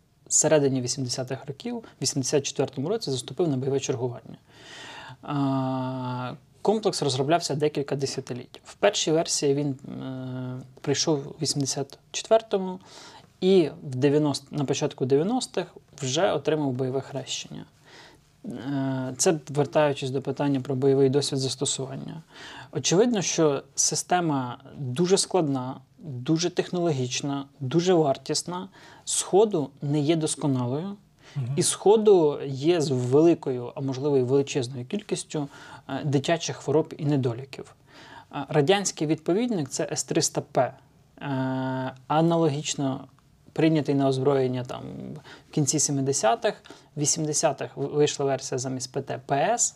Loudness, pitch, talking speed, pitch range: -25 LUFS, 145 Hz, 100 wpm, 135-160 Hz